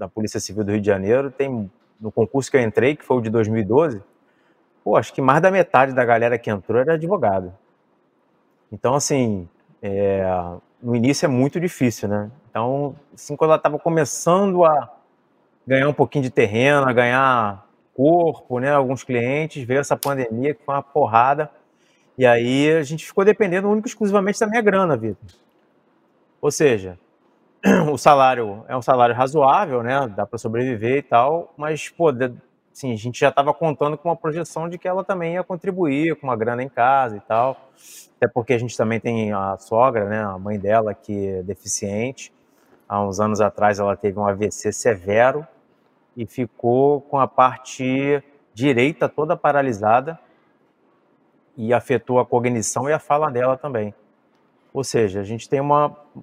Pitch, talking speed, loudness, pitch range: 130 Hz, 170 wpm, -20 LUFS, 110-145 Hz